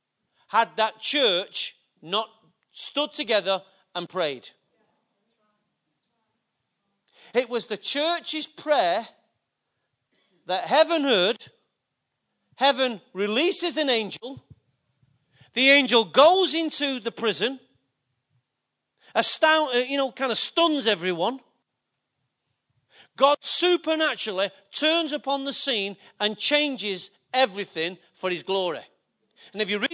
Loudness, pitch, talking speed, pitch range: -23 LUFS, 230 Hz, 95 wpm, 195-280 Hz